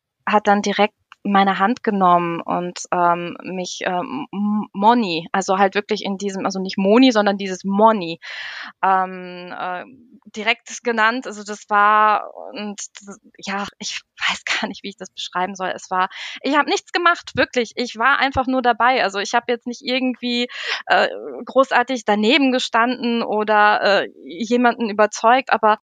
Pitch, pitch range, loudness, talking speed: 210 Hz, 195-245 Hz, -19 LUFS, 155 wpm